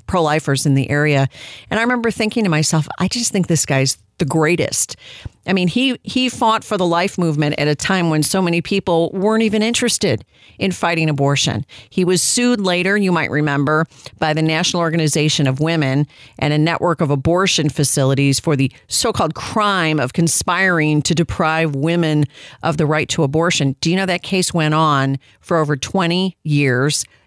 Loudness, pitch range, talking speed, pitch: -17 LUFS, 145-185 Hz, 185 wpm, 160 Hz